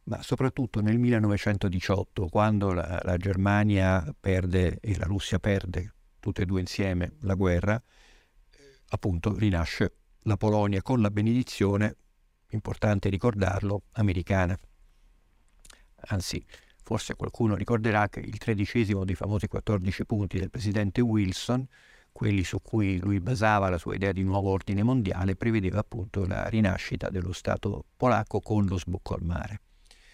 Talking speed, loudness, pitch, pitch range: 135 wpm, -28 LUFS, 100 Hz, 95-110 Hz